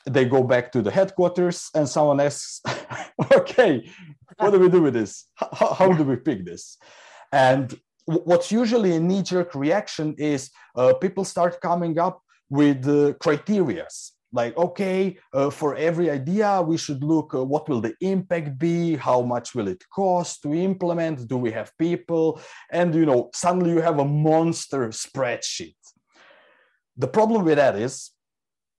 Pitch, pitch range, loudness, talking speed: 165 Hz, 140-180 Hz, -22 LUFS, 165 wpm